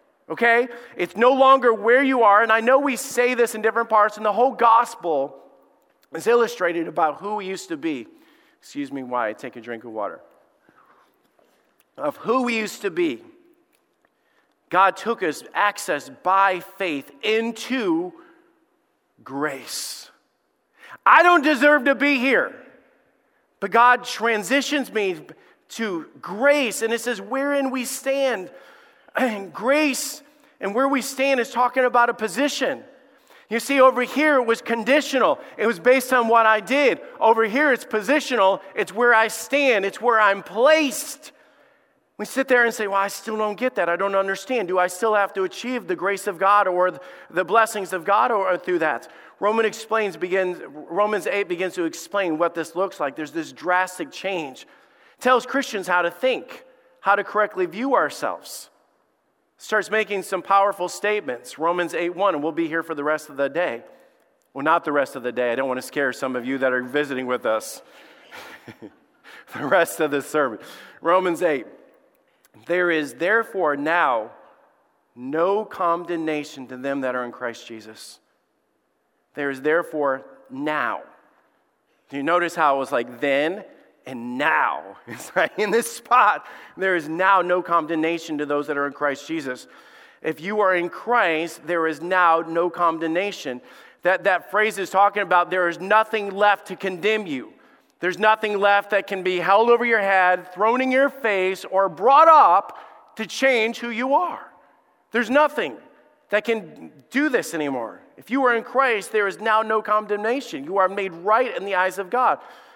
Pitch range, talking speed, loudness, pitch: 175-255 Hz, 175 wpm, -21 LUFS, 205 Hz